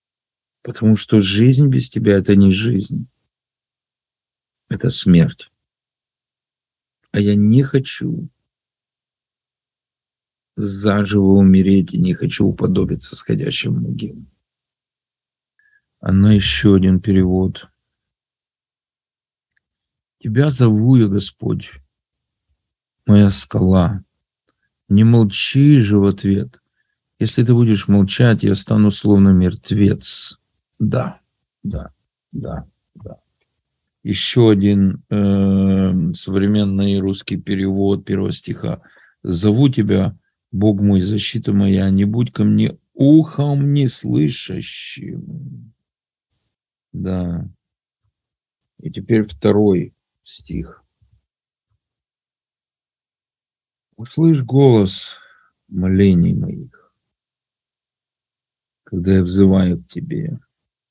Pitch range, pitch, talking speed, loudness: 95-130 Hz, 105 Hz, 85 wpm, -15 LUFS